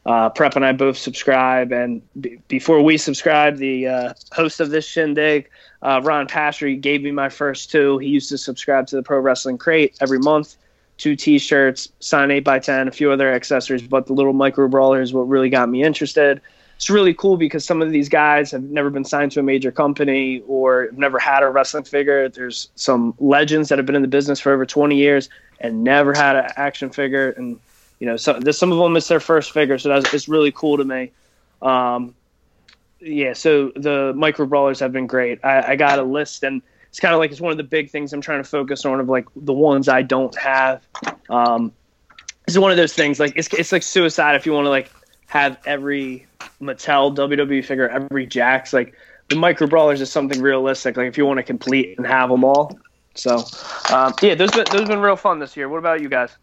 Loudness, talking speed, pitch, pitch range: -17 LUFS, 225 wpm, 140 Hz, 130-150 Hz